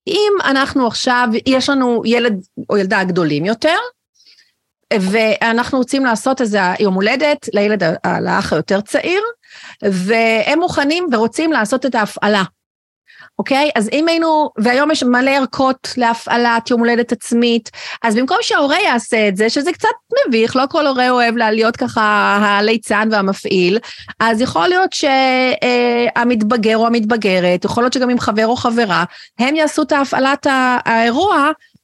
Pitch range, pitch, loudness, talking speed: 220-275 Hz, 240 Hz, -14 LUFS, 145 wpm